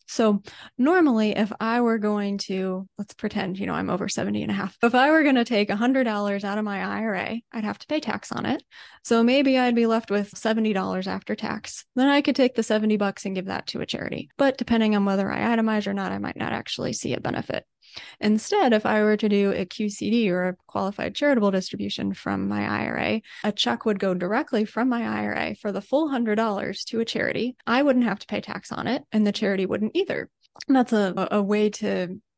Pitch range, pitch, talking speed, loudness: 195-235 Hz, 215 Hz, 225 wpm, -24 LUFS